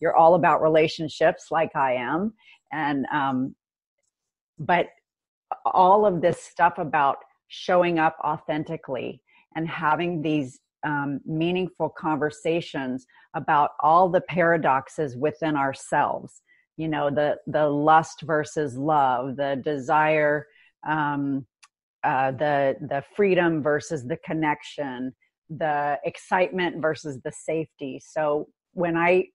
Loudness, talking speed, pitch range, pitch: -24 LUFS, 110 wpm, 145-165 Hz, 155 Hz